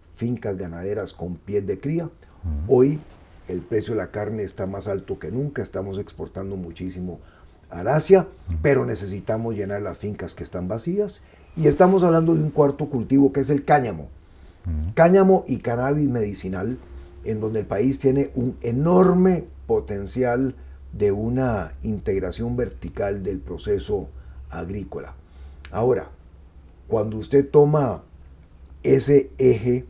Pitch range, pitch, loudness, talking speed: 85-135 Hz, 105 Hz, -22 LUFS, 130 wpm